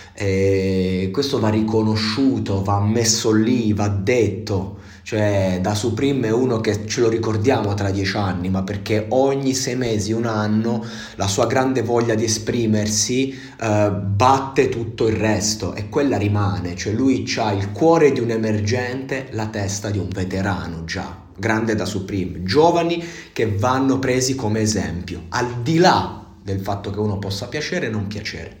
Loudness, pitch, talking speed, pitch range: -20 LUFS, 110 Hz, 160 wpm, 100-120 Hz